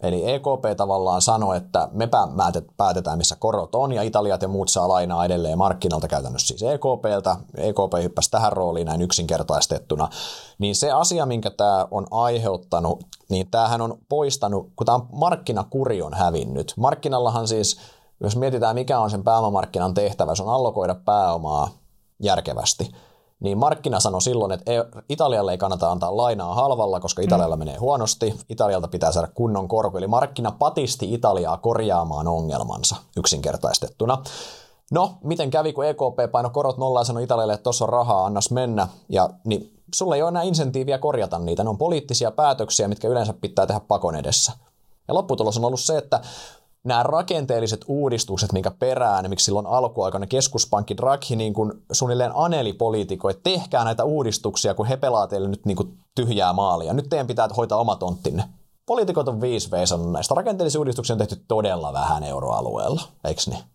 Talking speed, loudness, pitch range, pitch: 165 wpm, -22 LUFS, 95-125 Hz, 110 Hz